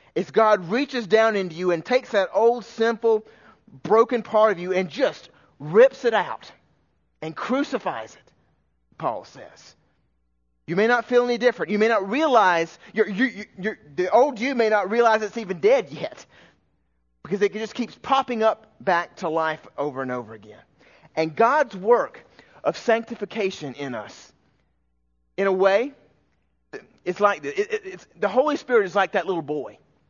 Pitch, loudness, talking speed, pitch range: 210 Hz, -22 LUFS, 170 wpm, 165-235 Hz